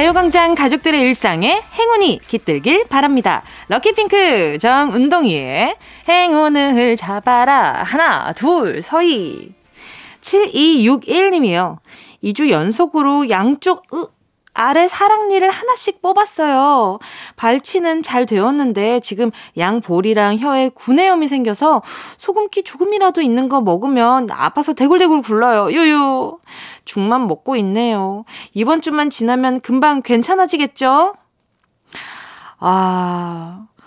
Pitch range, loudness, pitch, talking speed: 235-350 Hz, -14 LUFS, 280 Hz, 245 characters per minute